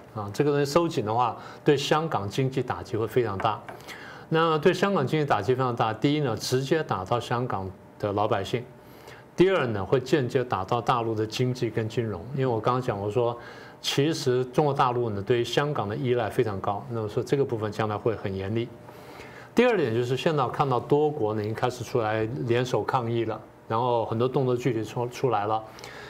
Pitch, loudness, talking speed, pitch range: 120 Hz, -26 LUFS, 310 characters per minute, 110-135 Hz